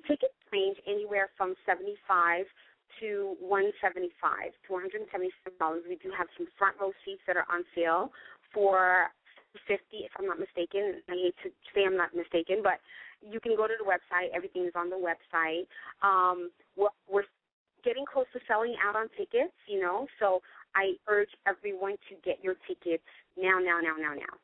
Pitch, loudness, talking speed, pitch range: 195 Hz, -31 LUFS, 170 wpm, 180-220 Hz